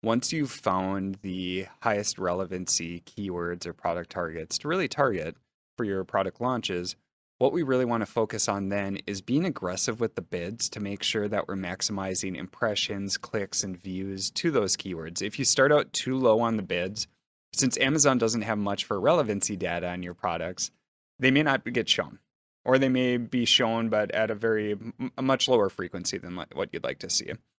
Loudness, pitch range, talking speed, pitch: -27 LUFS, 95-120 Hz, 190 wpm, 100 Hz